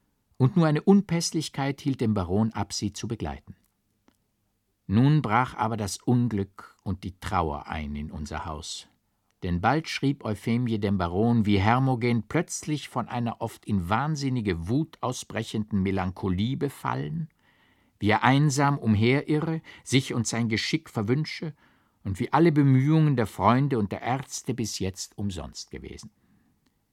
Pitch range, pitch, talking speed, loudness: 100-135 Hz, 115 Hz, 140 wpm, -26 LUFS